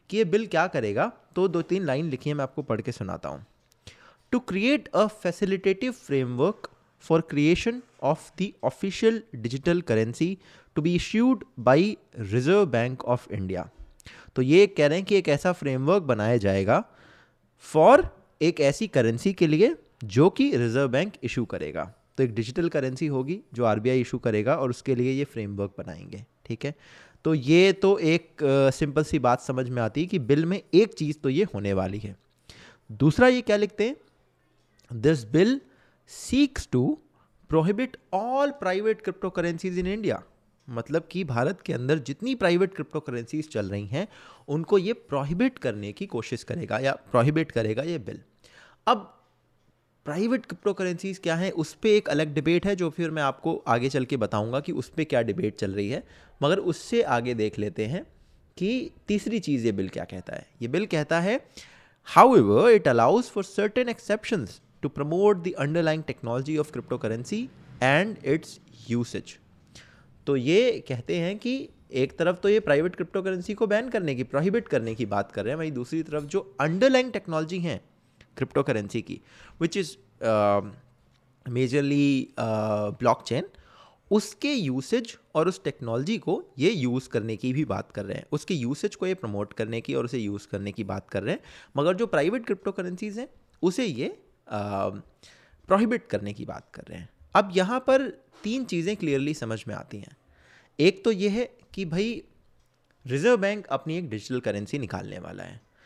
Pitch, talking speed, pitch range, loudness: 155 Hz, 175 wpm, 125-195 Hz, -26 LUFS